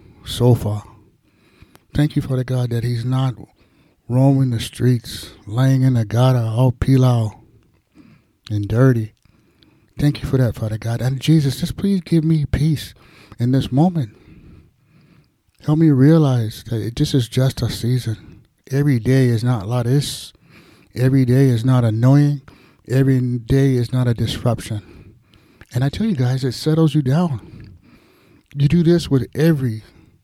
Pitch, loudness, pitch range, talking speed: 125 Hz, -18 LUFS, 115-140 Hz, 155 wpm